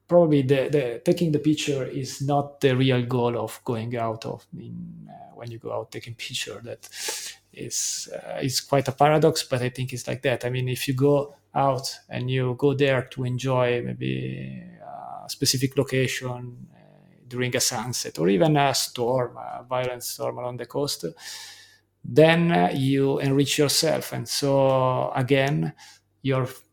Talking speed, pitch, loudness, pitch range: 165 wpm, 135 Hz, -24 LUFS, 125-145 Hz